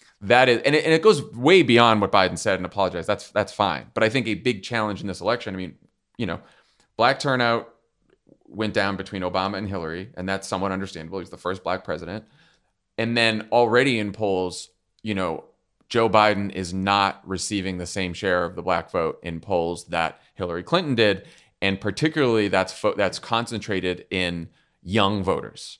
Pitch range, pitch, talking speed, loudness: 95-115 Hz, 100 Hz, 190 wpm, -23 LUFS